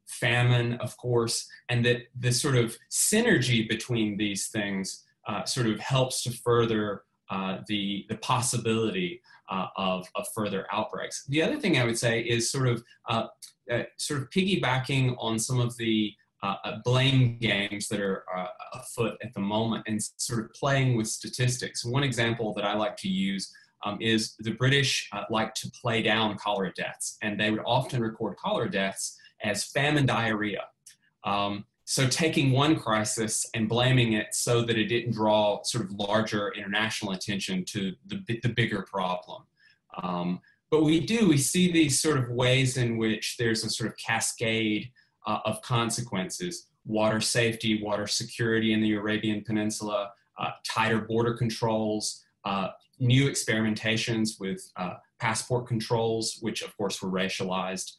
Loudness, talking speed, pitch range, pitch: -27 LUFS, 160 wpm, 105-125 Hz, 115 Hz